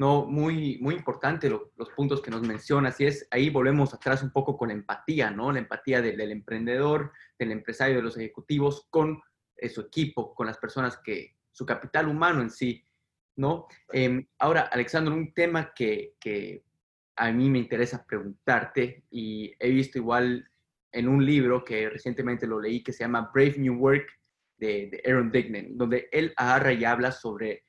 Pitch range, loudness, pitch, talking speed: 120-140 Hz, -27 LUFS, 130 Hz, 185 wpm